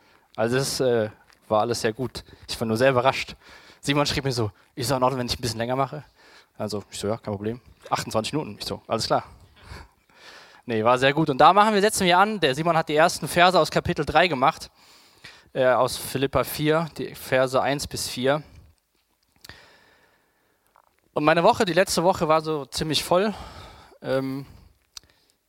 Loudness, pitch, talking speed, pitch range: -23 LUFS, 135 Hz, 185 wpm, 115-155 Hz